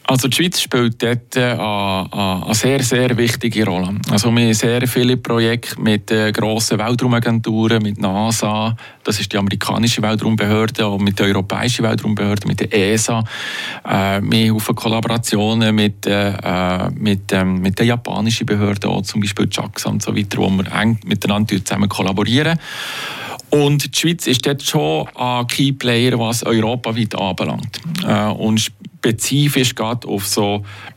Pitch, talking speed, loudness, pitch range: 110 Hz, 145 wpm, -17 LUFS, 105-120 Hz